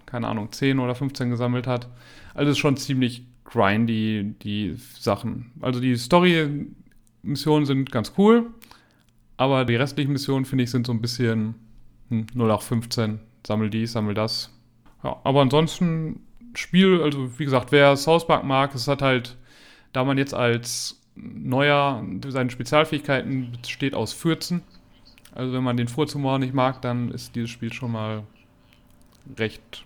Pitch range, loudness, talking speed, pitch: 115-140 Hz, -23 LUFS, 155 wpm, 125 Hz